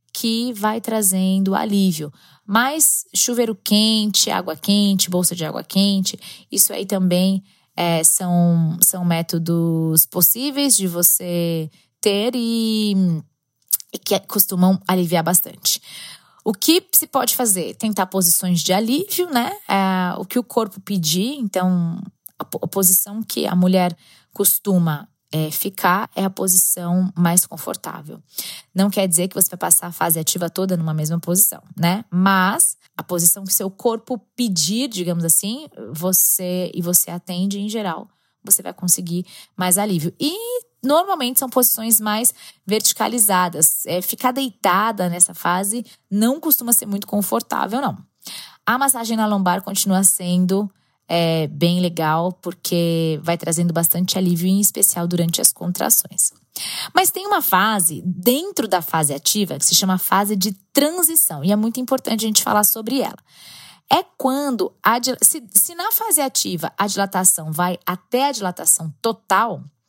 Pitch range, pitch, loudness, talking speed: 175-225 Hz, 190 Hz, -18 LUFS, 145 wpm